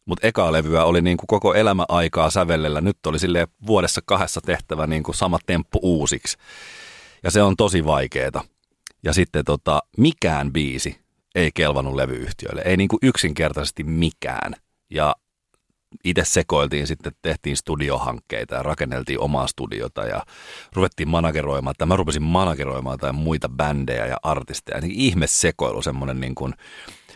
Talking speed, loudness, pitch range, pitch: 140 wpm, -21 LUFS, 70-85 Hz, 80 Hz